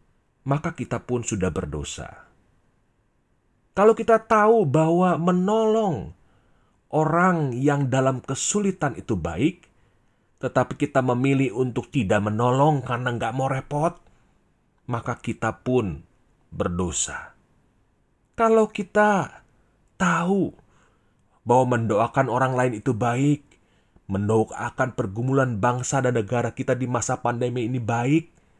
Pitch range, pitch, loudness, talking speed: 120-145 Hz, 130 Hz, -23 LUFS, 105 wpm